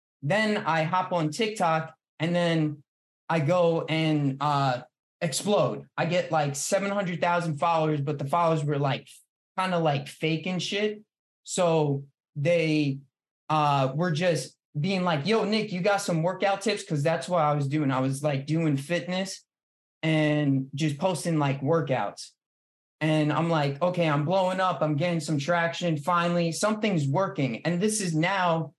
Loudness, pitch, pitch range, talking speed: -26 LUFS, 165 Hz, 150-180 Hz, 155 wpm